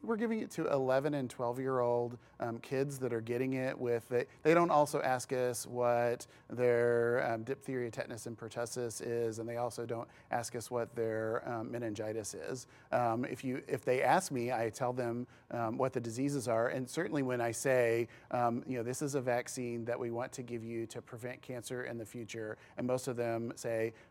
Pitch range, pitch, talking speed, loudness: 115-130 Hz, 120 Hz, 210 wpm, -36 LUFS